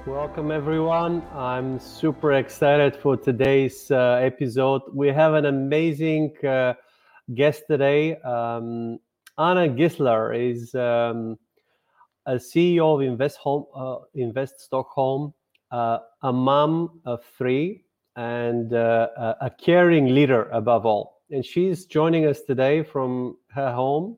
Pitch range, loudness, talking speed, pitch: 125-155 Hz, -22 LUFS, 120 wpm, 135 Hz